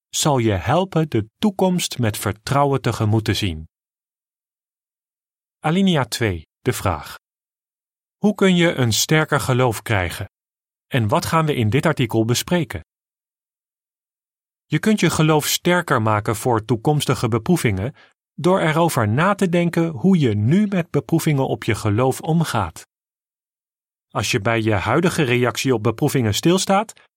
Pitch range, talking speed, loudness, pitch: 110-165 Hz, 135 wpm, -19 LUFS, 130 Hz